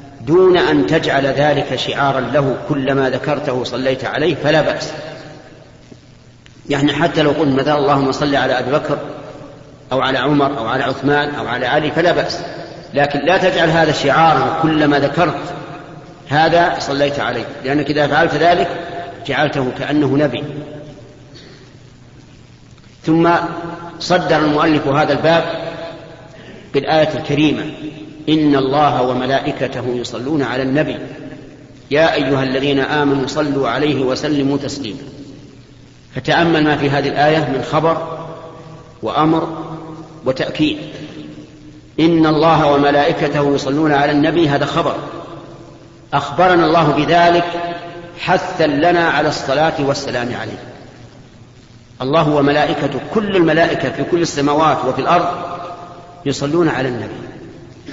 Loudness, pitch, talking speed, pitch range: -15 LUFS, 145 Hz, 115 wpm, 135-160 Hz